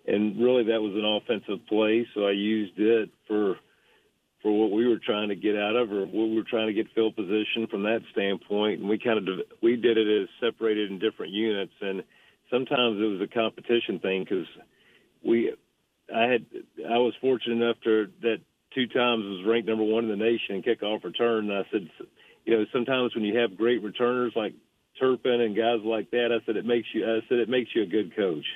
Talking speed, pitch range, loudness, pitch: 220 wpm, 105-115 Hz, -26 LUFS, 110 Hz